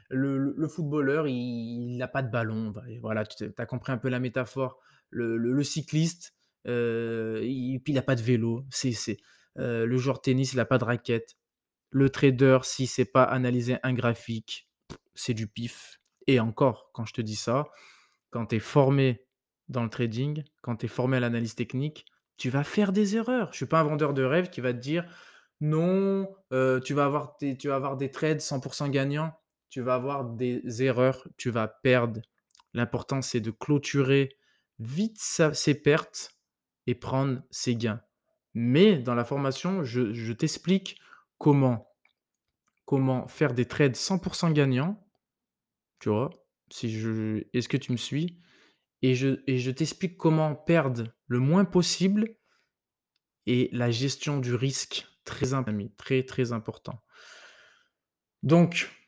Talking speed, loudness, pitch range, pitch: 165 wpm, -28 LUFS, 120-150 Hz, 130 Hz